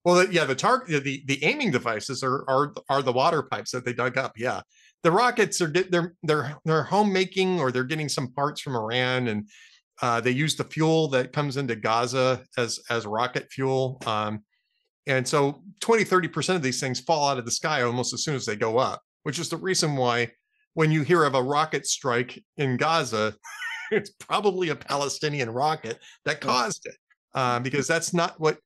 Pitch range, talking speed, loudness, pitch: 125-165 Hz, 195 wpm, -25 LUFS, 140 Hz